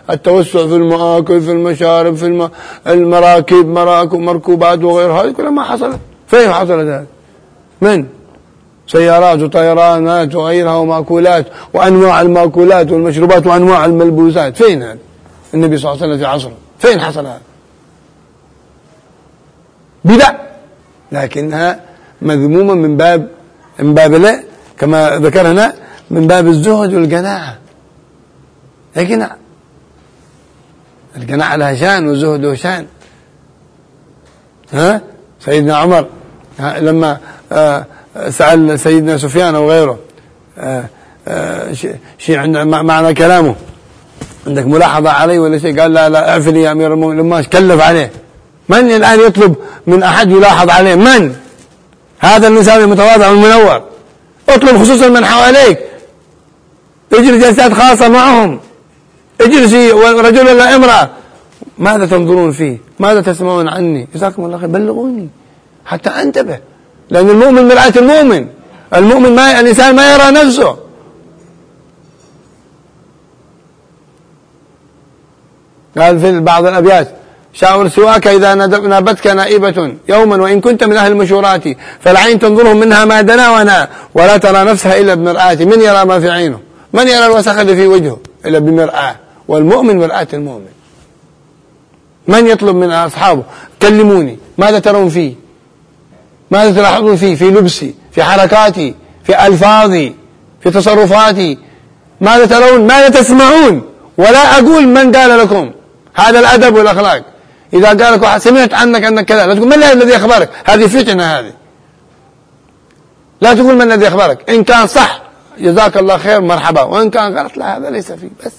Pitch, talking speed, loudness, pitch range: 180 Hz, 125 wpm, -7 LUFS, 160-215 Hz